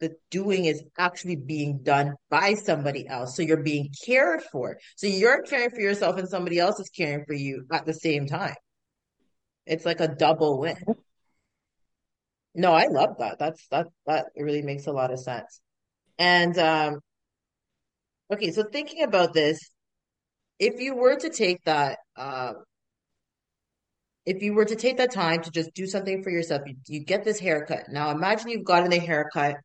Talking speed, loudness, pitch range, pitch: 175 wpm, -25 LUFS, 150-195 Hz, 165 Hz